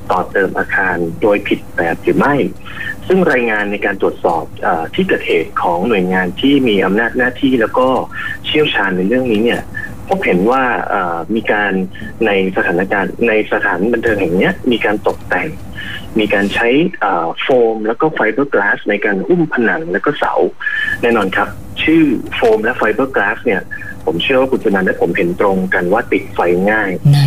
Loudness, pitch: -14 LUFS, 130 Hz